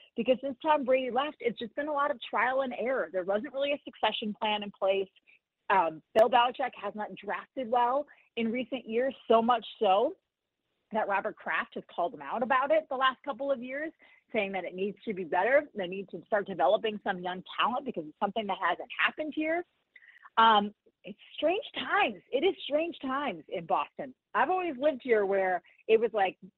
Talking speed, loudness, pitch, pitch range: 200 wpm, -30 LUFS, 235 Hz, 200-285 Hz